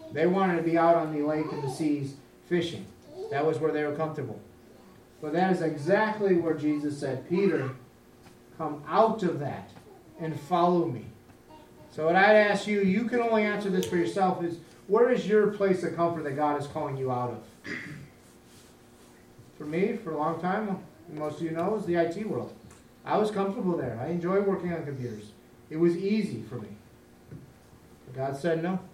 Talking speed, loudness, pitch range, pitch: 190 wpm, -28 LUFS, 140-185 Hz, 165 Hz